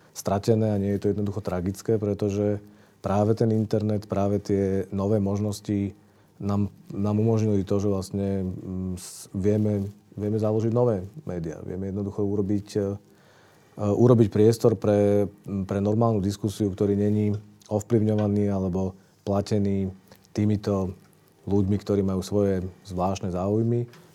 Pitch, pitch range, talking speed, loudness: 100 Hz, 100-105 Hz, 115 wpm, -25 LUFS